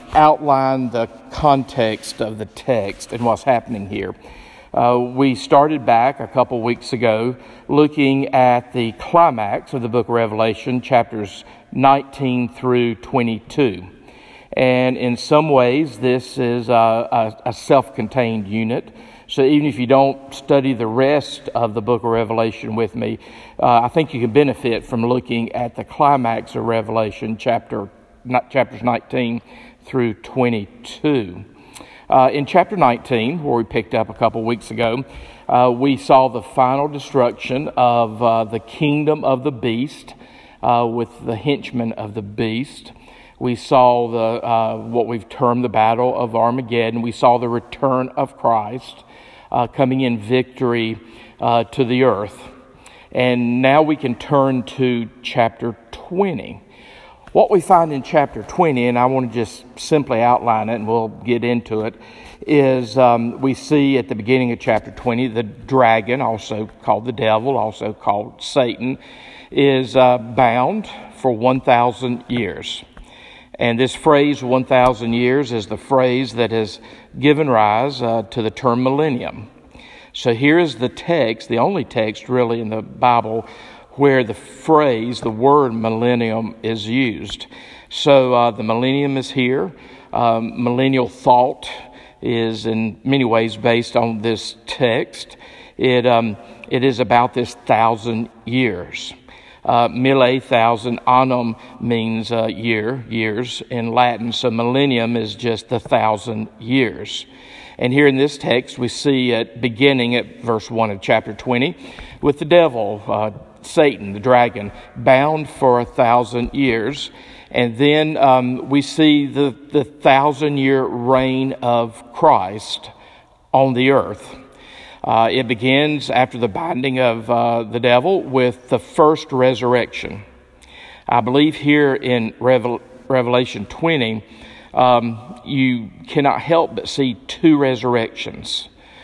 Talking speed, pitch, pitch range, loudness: 145 wpm, 125 Hz, 115-135 Hz, -17 LUFS